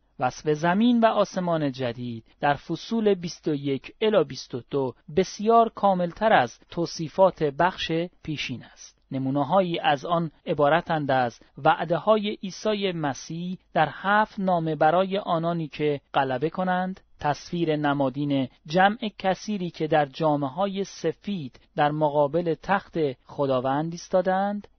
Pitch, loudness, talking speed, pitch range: 165 Hz, -25 LUFS, 115 wpm, 145-190 Hz